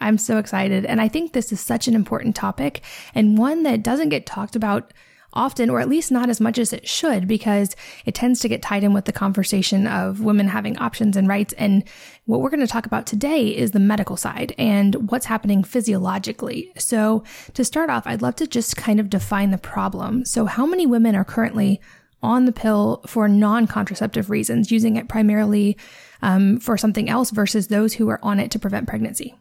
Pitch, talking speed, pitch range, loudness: 215 Hz, 210 wpm, 205-235 Hz, -20 LUFS